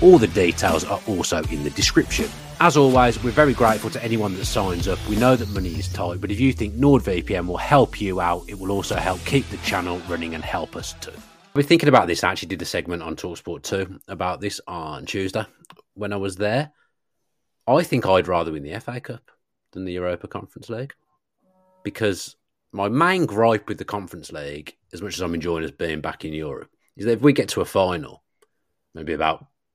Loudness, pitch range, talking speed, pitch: -22 LUFS, 90-125 Hz, 215 wpm, 105 Hz